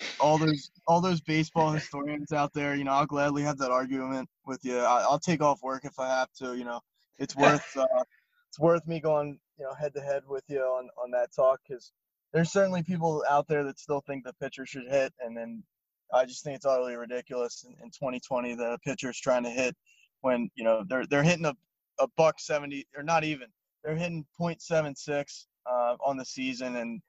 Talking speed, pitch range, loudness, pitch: 220 wpm, 130-155 Hz, -29 LUFS, 140 Hz